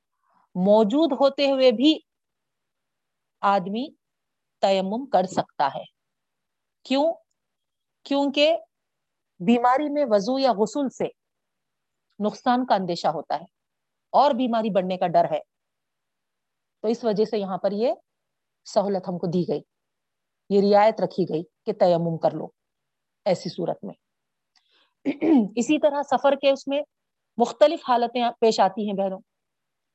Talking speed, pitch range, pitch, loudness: 125 wpm, 195-275 Hz, 230 Hz, -23 LUFS